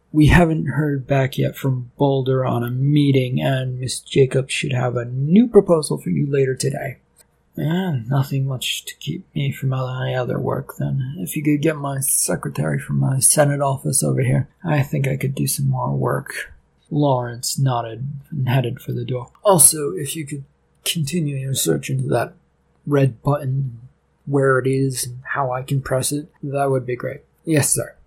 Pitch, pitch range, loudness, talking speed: 135 Hz, 130-145 Hz, -20 LUFS, 185 wpm